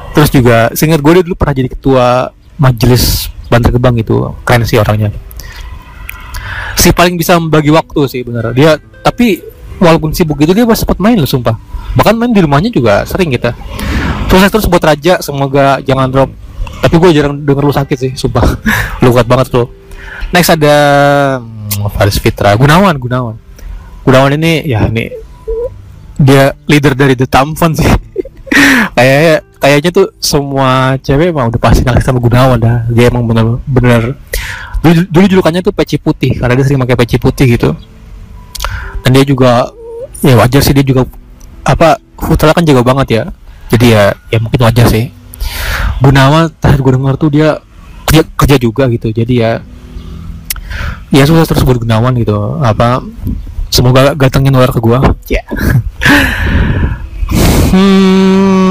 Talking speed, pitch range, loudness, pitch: 155 wpm, 110-150 Hz, -9 LUFS, 130 Hz